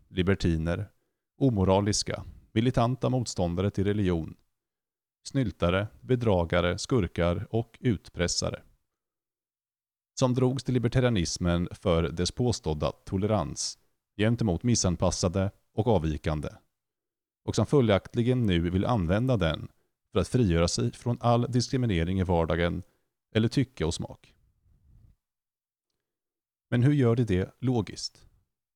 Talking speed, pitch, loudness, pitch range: 100 wpm, 105 Hz, -28 LUFS, 90-120 Hz